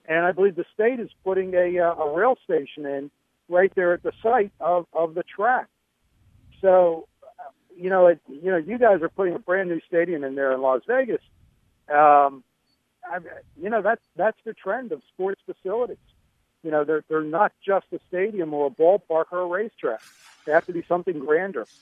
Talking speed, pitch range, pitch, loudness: 195 wpm, 155-200 Hz, 175 Hz, -23 LUFS